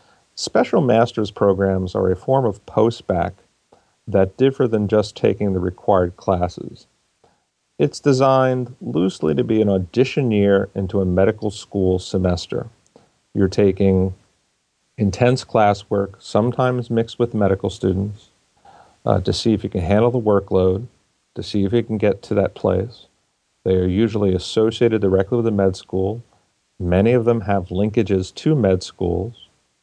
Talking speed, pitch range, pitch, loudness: 145 wpm, 95-115 Hz, 100 Hz, -19 LUFS